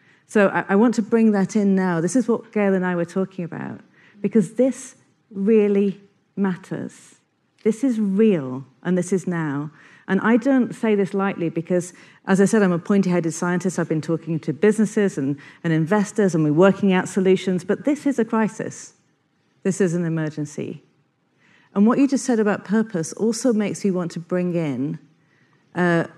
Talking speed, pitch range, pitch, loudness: 185 wpm, 165-215 Hz, 195 Hz, -21 LUFS